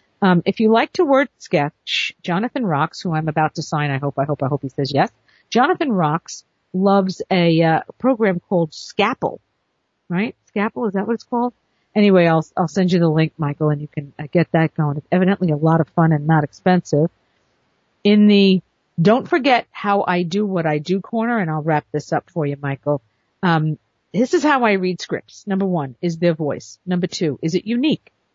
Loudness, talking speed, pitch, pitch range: -19 LUFS, 205 wpm, 175 Hz, 155-200 Hz